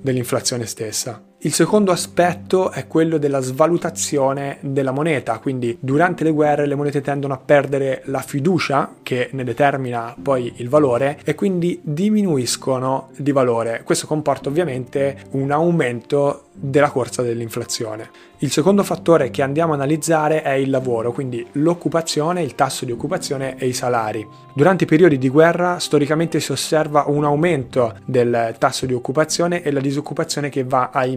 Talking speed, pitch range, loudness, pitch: 155 wpm, 130-160 Hz, -19 LUFS, 140 Hz